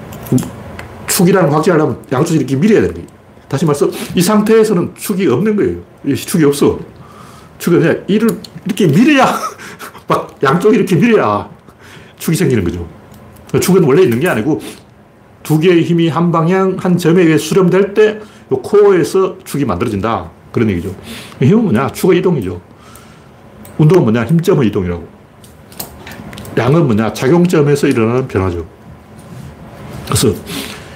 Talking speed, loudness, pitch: 300 characters per minute, -12 LUFS, 165 Hz